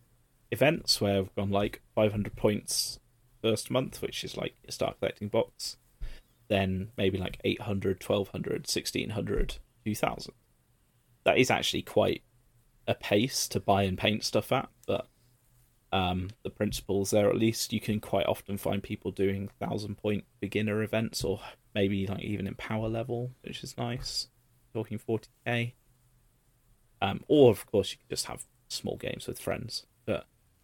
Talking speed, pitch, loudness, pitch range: 155 wpm, 110 Hz, -31 LUFS, 100-120 Hz